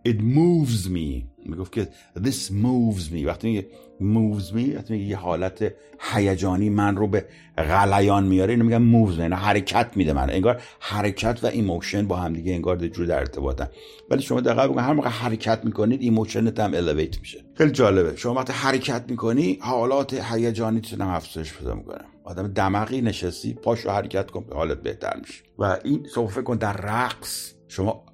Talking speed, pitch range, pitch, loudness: 170 wpm, 95-115 Hz, 105 Hz, -23 LUFS